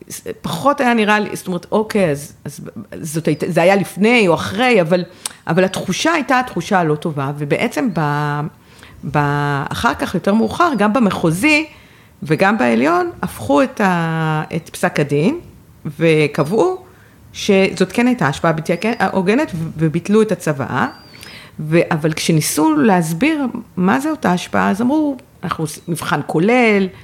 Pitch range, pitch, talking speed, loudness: 160-230 Hz, 185 Hz, 140 wpm, -16 LUFS